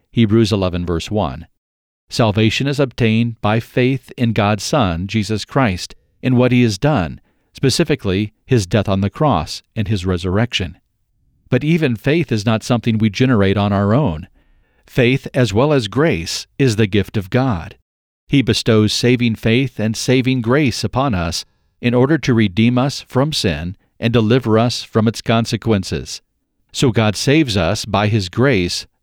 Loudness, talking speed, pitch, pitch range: -16 LUFS, 160 wpm, 115 Hz, 100-125 Hz